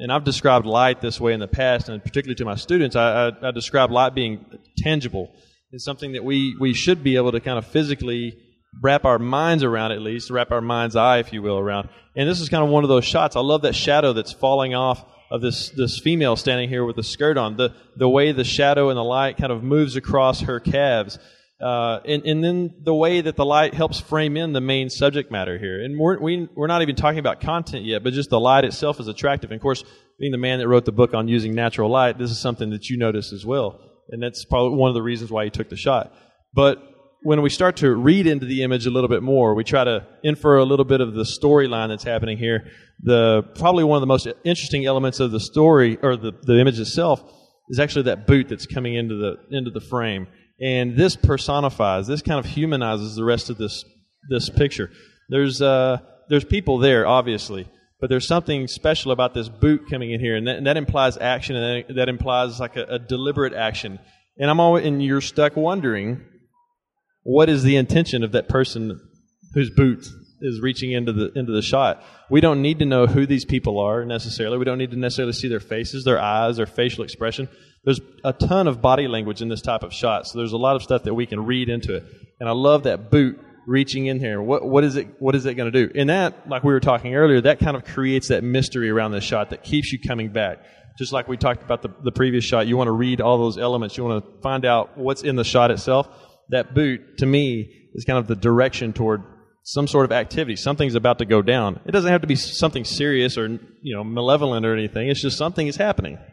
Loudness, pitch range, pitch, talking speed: -20 LUFS, 115-140 Hz, 130 Hz, 240 wpm